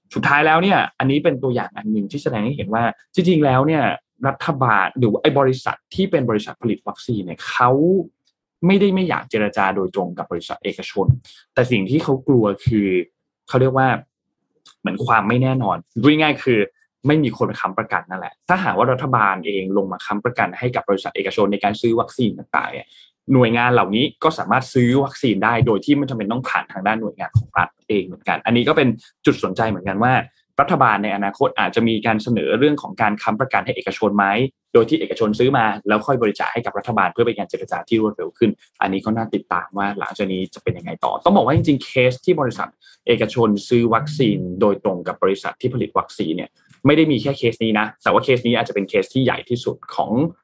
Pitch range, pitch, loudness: 105-140 Hz, 120 Hz, -19 LUFS